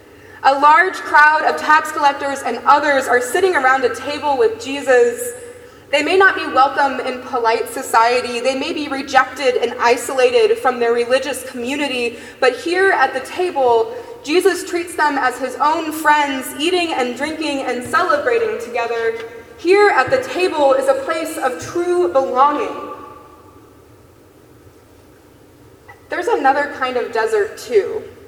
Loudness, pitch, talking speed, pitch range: -16 LUFS, 290 Hz, 140 wpm, 260-365 Hz